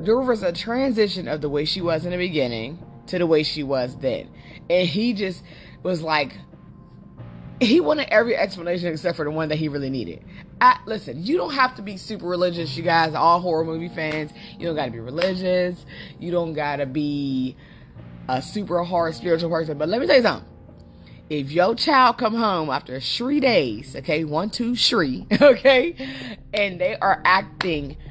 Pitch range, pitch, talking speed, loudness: 150-205 Hz, 170 Hz, 185 wpm, -22 LUFS